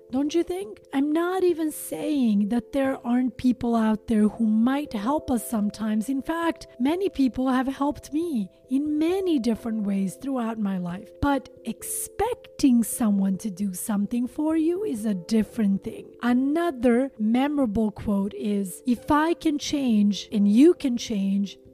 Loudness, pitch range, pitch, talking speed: -25 LUFS, 215-295 Hz, 245 Hz, 155 wpm